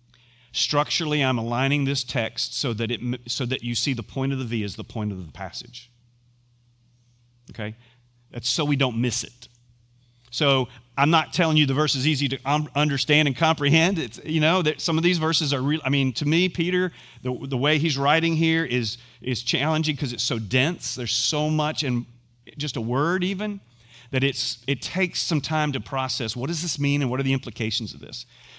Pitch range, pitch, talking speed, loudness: 120-150 Hz, 130 Hz, 210 wpm, -24 LUFS